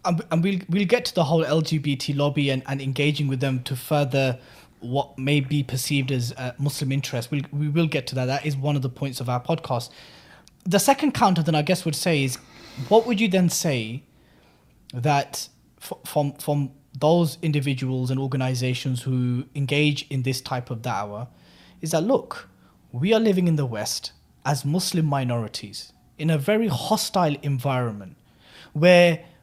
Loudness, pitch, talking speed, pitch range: -23 LUFS, 145 Hz, 175 wpm, 130-160 Hz